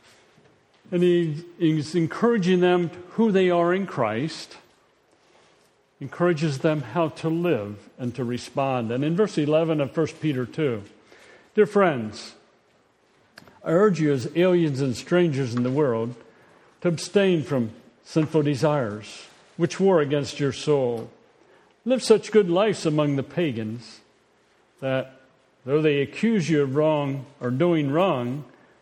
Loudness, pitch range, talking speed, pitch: -23 LUFS, 130-175 Hz, 135 wpm, 155 Hz